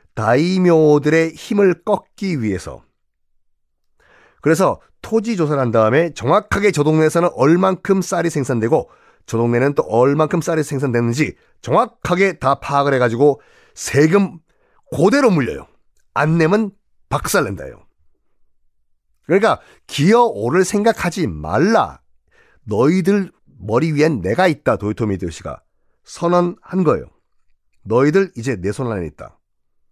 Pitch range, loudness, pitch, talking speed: 115-180 Hz, -17 LUFS, 150 Hz, 270 characters per minute